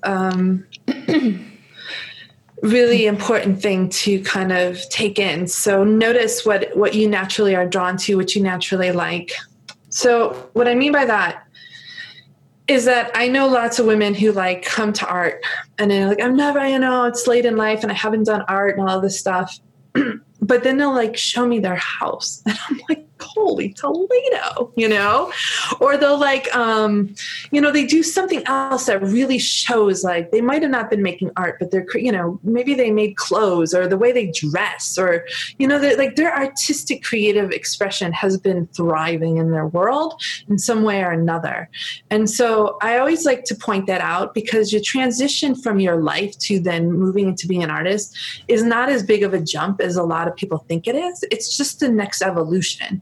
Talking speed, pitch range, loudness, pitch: 195 wpm, 190-255 Hz, -18 LUFS, 215 Hz